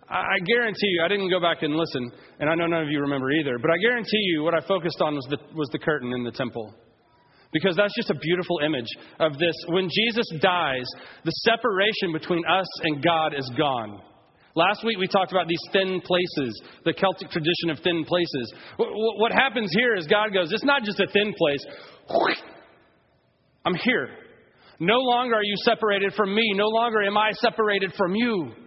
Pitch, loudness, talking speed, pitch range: 180 Hz, -23 LUFS, 195 wpm, 155-210 Hz